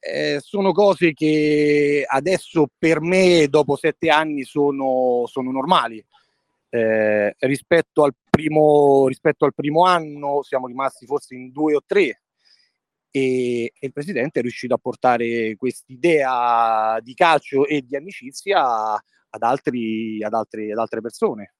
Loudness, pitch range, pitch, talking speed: -19 LUFS, 120-155 Hz, 140 Hz, 135 wpm